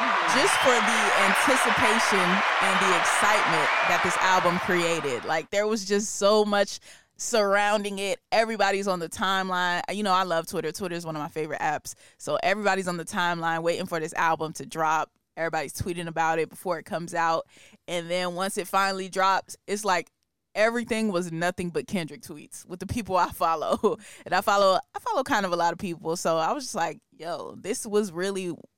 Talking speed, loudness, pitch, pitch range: 195 wpm, -25 LUFS, 180 Hz, 165-200 Hz